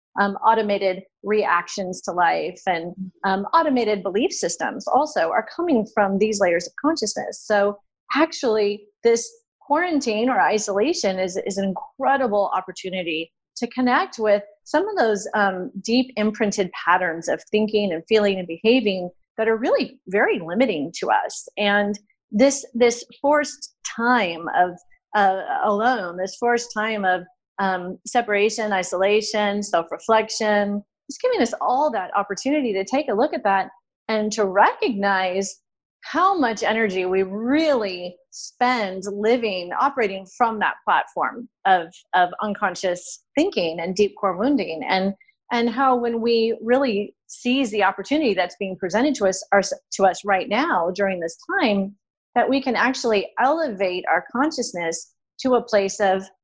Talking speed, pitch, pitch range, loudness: 140 wpm, 210 Hz, 190-250 Hz, -22 LUFS